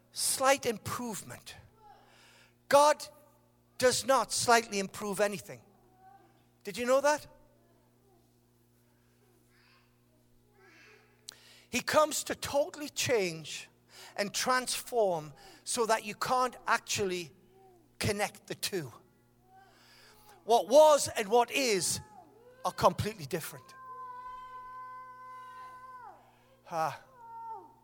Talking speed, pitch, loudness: 80 wpm, 245 Hz, -30 LUFS